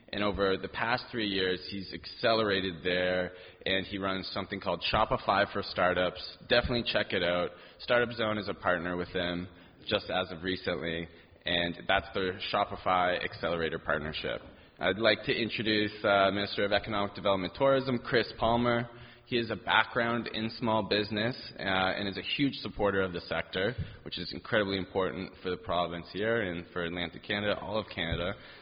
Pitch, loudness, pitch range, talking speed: 100 Hz, -31 LUFS, 90-110 Hz, 170 wpm